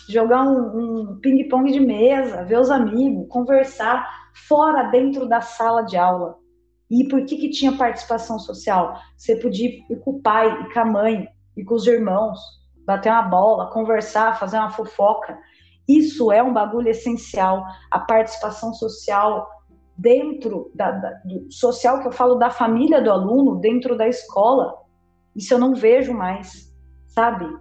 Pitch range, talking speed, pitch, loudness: 210-250 Hz, 160 wpm, 230 Hz, -19 LUFS